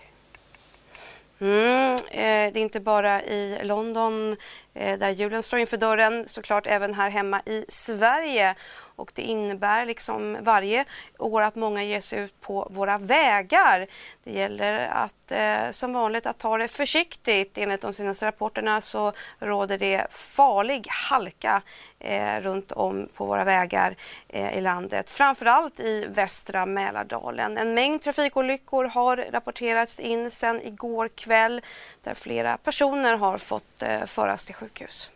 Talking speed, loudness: 145 wpm, -24 LUFS